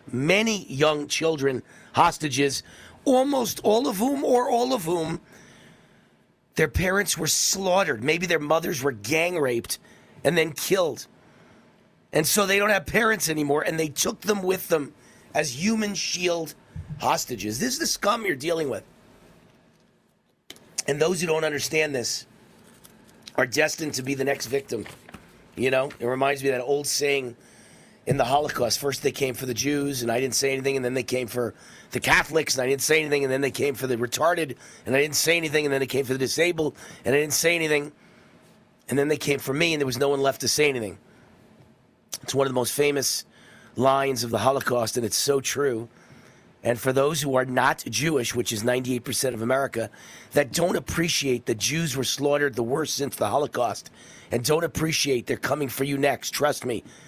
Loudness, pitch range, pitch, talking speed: -24 LUFS, 130-160 Hz, 140 Hz, 195 wpm